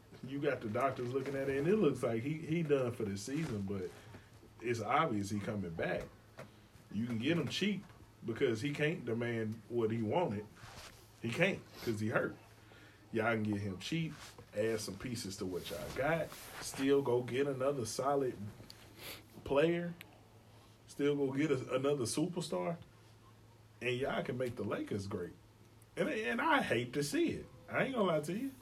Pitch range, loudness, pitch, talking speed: 110-140 Hz, -37 LUFS, 115 Hz, 175 wpm